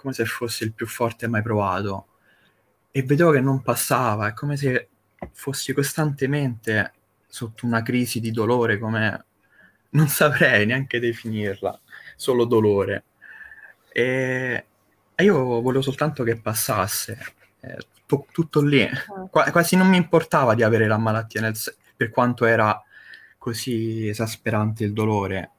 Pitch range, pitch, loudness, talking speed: 110-135 Hz, 115 Hz, -22 LUFS, 140 wpm